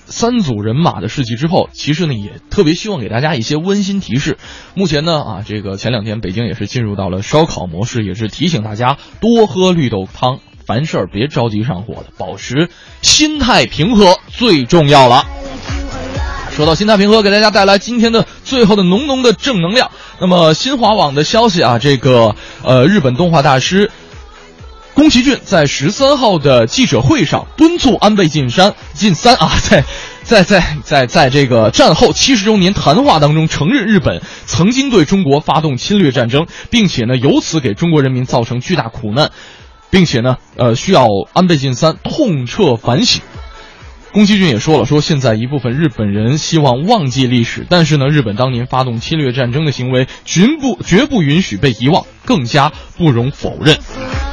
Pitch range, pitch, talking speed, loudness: 125-195 Hz, 155 Hz, 280 characters per minute, -12 LUFS